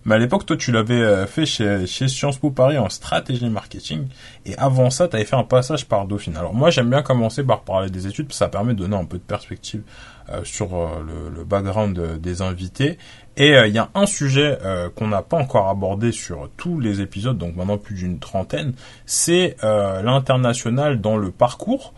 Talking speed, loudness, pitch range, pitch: 215 wpm, -20 LUFS, 95-130 Hz, 110 Hz